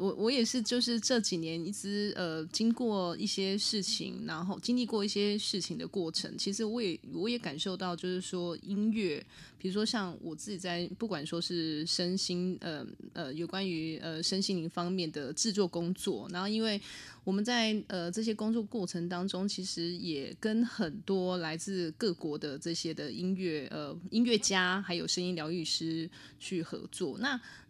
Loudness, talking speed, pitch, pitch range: -34 LUFS, 260 characters per minute, 185 Hz, 170-210 Hz